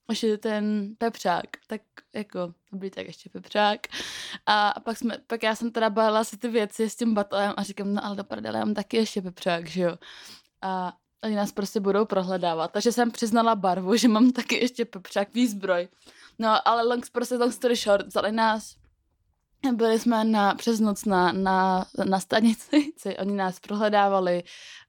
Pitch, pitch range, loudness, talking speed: 210 Hz, 195-230 Hz, -25 LUFS, 175 wpm